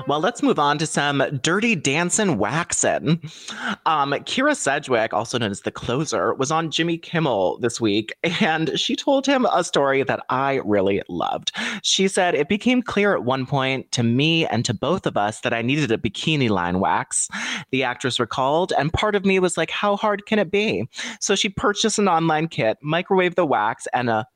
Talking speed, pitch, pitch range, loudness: 195 wpm, 160 Hz, 130-200 Hz, -21 LUFS